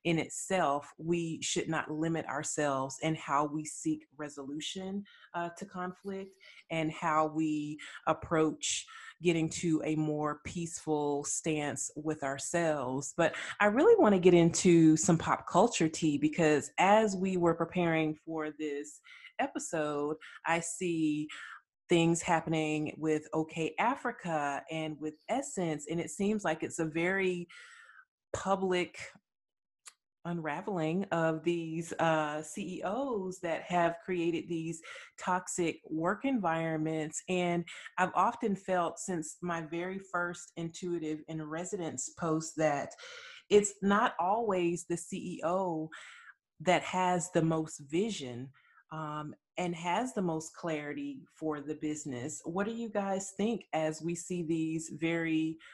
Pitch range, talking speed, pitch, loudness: 155-180 Hz, 125 wpm, 165 Hz, -32 LUFS